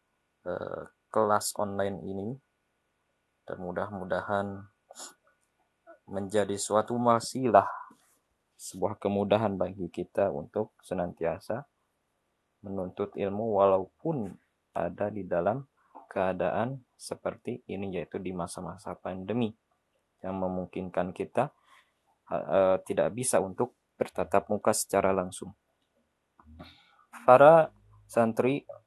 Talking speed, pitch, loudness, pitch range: 80 wpm, 100 Hz, -29 LUFS, 90-105 Hz